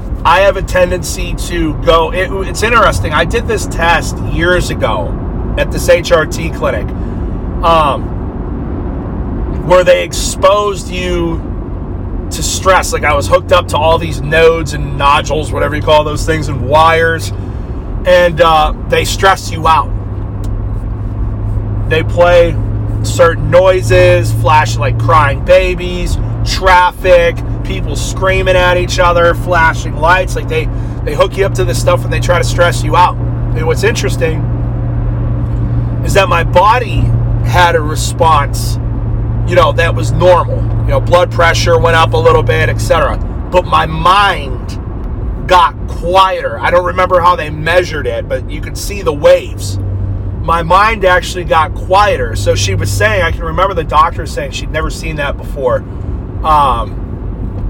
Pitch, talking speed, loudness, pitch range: 115 Hz, 155 wpm, -11 LUFS, 105-150 Hz